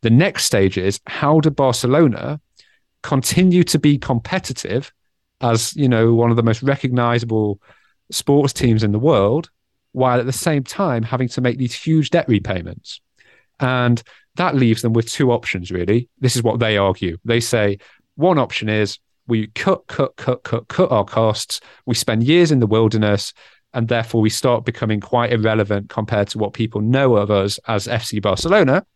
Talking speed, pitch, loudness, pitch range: 175 wpm, 120 Hz, -18 LUFS, 110-135 Hz